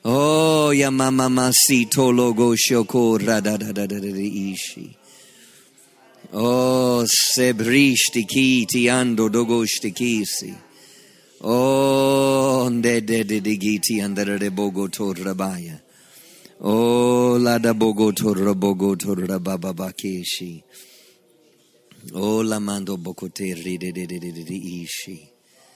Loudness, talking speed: -19 LUFS, 70 wpm